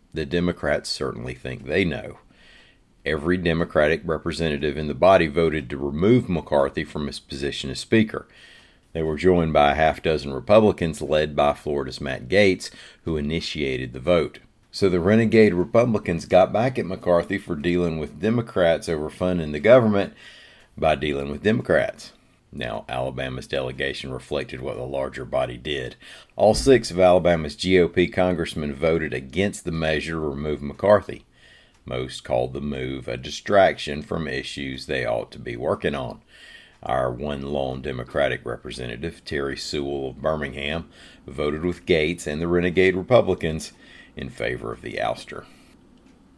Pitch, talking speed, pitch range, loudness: 80 Hz, 150 wpm, 70-90 Hz, -23 LUFS